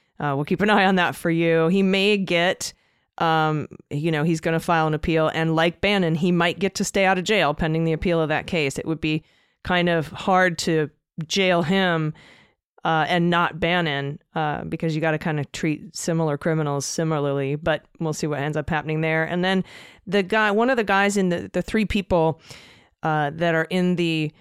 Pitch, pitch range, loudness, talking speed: 165 Hz, 155-180 Hz, -22 LUFS, 215 wpm